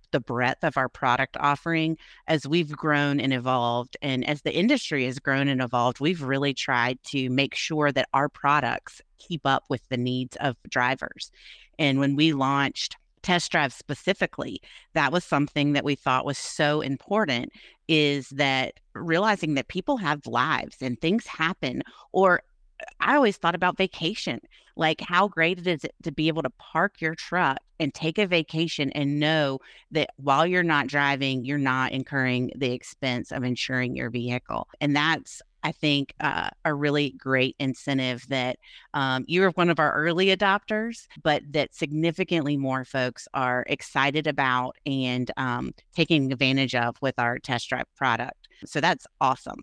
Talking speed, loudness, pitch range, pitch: 165 wpm, -25 LUFS, 130-160 Hz, 145 Hz